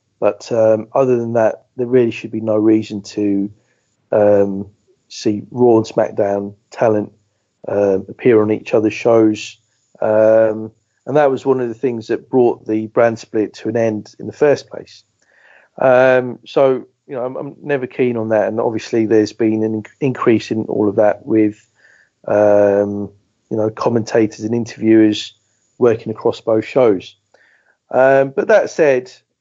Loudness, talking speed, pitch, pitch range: -16 LUFS, 160 wpm, 110 Hz, 105-120 Hz